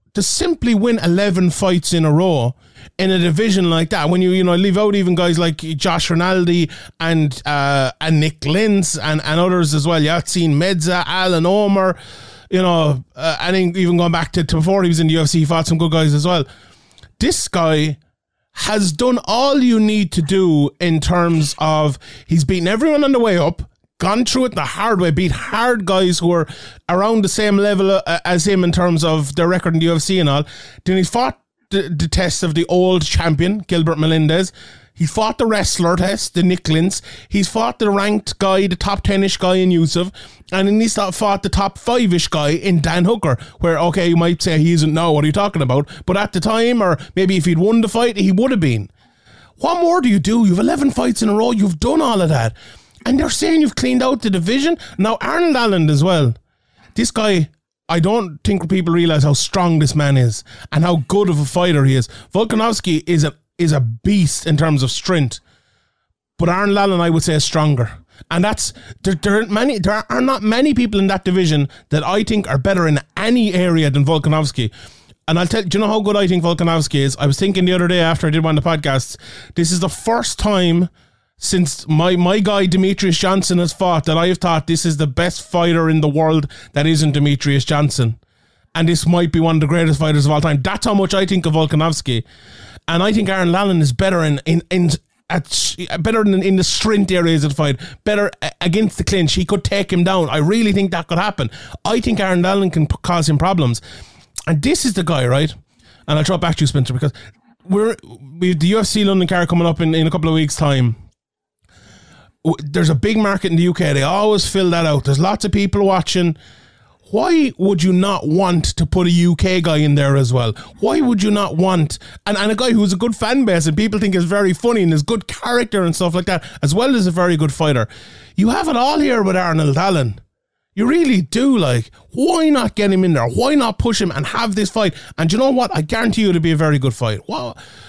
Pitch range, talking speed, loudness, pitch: 155-200 Hz, 225 wpm, -16 LUFS, 175 Hz